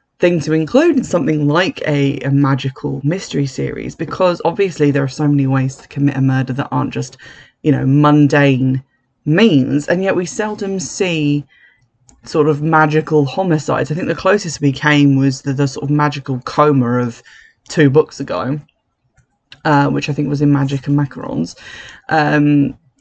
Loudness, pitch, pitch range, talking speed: -15 LUFS, 145 Hz, 135-155 Hz, 170 wpm